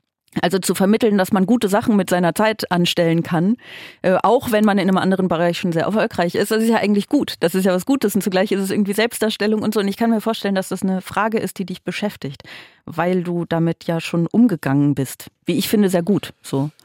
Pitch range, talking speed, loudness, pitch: 175-215 Hz, 240 wpm, -18 LUFS, 190 Hz